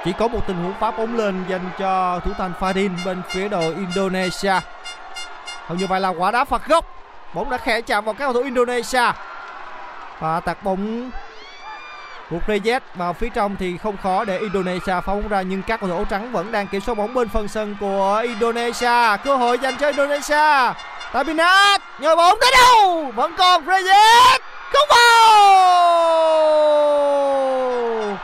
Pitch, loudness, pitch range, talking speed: 225 Hz, -17 LUFS, 190-290 Hz, 170 wpm